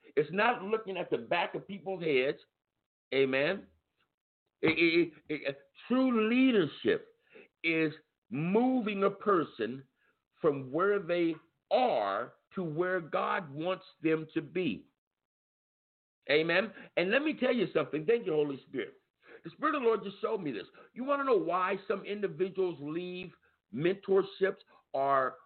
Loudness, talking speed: -31 LUFS, 145 wpm